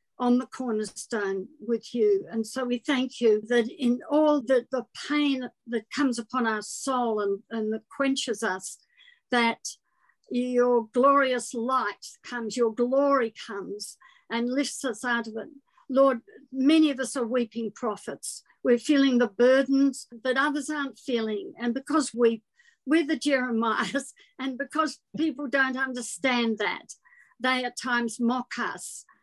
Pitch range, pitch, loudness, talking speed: 230-275 Hz, 250 Hz, -26 LUFS, 150 wpm